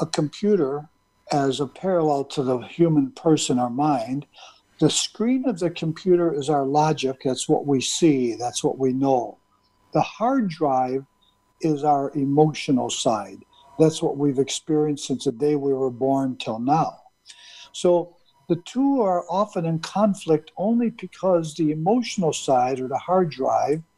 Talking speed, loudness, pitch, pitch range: 155 wpm, -22 LUFS, 150 Hz, 135-175 Hz